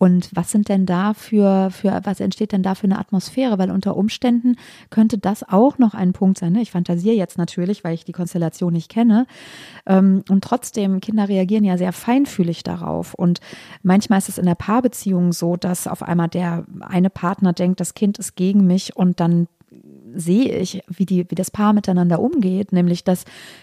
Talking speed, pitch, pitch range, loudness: 195 wpm, 190 Hz, 175-210 Hz, -19 LUFS